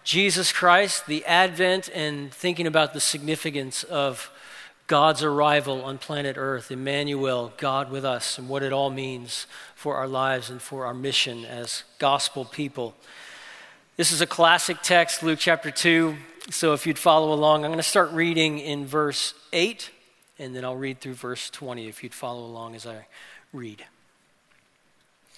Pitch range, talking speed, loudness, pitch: 130-160 Hz, 165 wpm, -23 LUFS, 145 Hz